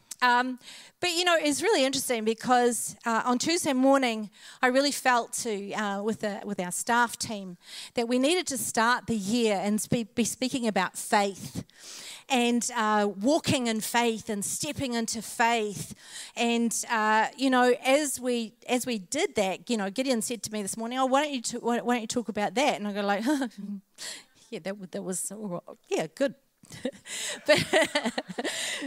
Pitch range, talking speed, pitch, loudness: 210-255 Hz, 175 wpm, 235 Hz, -27 LUFS